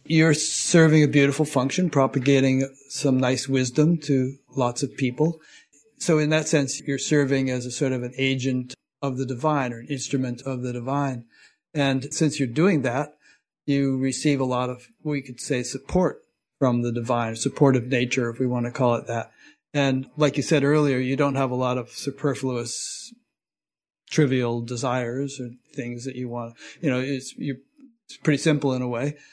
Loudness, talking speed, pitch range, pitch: -24 LUFS, 180 wpm, 125-145 Hz, 135 Hz